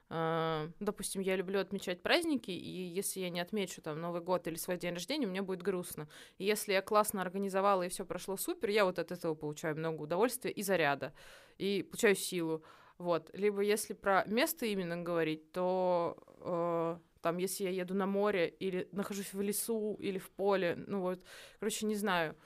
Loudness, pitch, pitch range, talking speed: -35 LUFS, 190 Hz, 175-205 Hz, 180 wpm